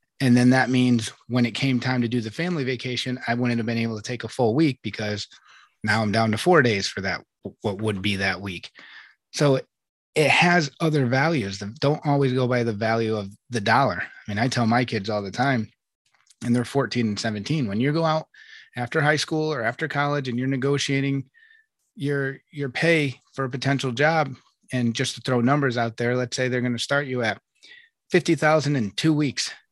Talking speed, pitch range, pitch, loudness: 215 wpm, 115-145 Hz, 125 Hz, -23 LUFS